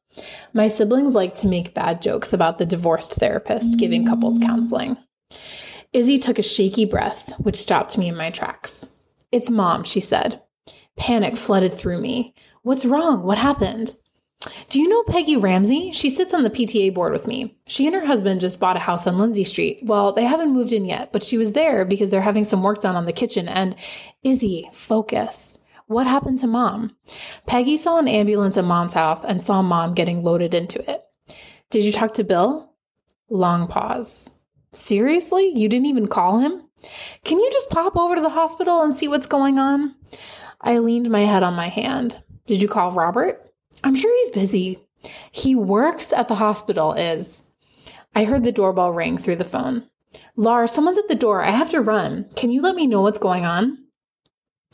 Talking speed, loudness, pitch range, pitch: 190 wpm, -19 LUFS, 195-265 Hz, 225 Hz